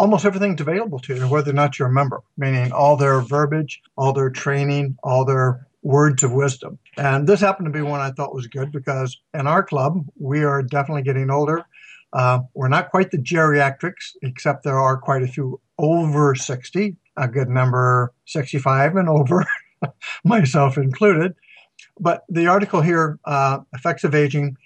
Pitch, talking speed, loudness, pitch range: 140 Hz, 175 wpm, -19 LUFS, 135-160 Hz